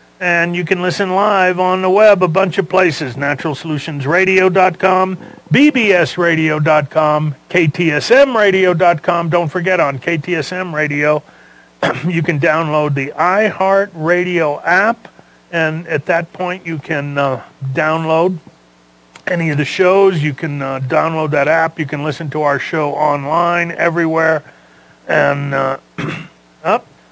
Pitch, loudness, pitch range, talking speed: 160 Hz, -14 LUFS, 150-180 Hz, 120 wpm